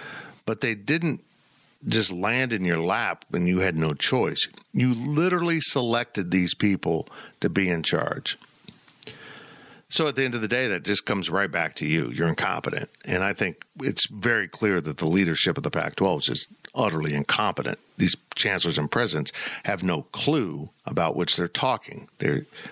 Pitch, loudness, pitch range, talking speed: 100 Hz, -25 LUFS, 90-130 Hz, 175 wpm